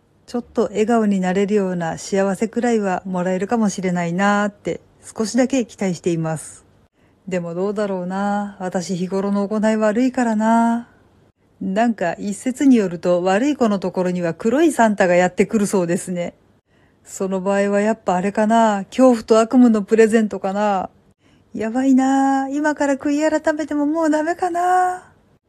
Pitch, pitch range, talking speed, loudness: 210 Hz, 190-240 Hz, 345 characters per minute, -19 LUFS